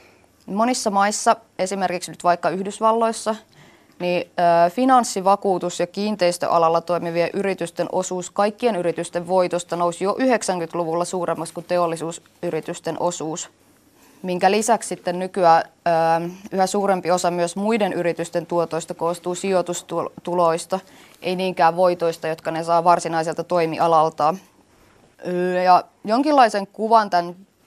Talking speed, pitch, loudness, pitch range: 105 wpm, 175 Hz, -21 LUFS, 170-195 Hz